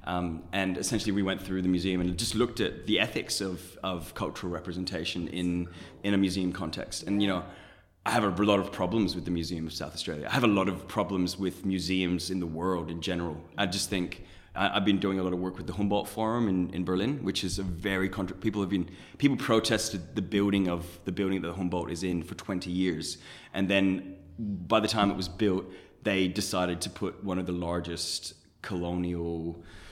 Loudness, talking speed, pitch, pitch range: -30 LUFS, 215 wpm, 95 Hz, 90-100 Hz